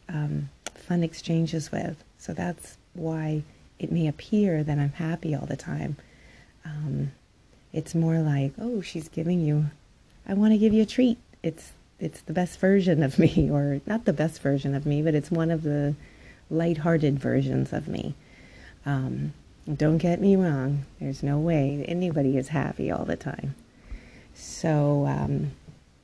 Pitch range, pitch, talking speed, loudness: 140-170 Hz, 155 Hz, 160 wpm, -26 LUFS